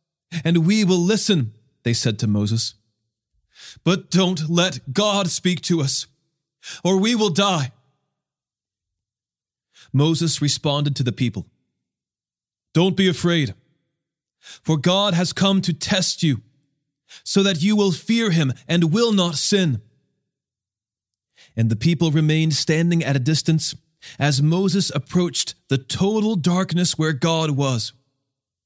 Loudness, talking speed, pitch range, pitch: -20 LUFS, 130 wpm, 130-180 Hz, 155 Hz